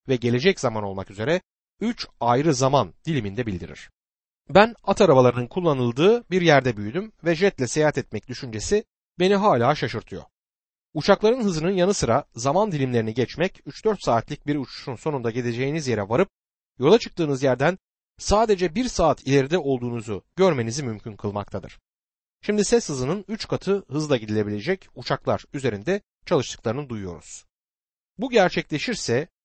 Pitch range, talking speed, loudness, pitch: 120-185 Hz, 130 wpm, -23 LUFS, 140 Hz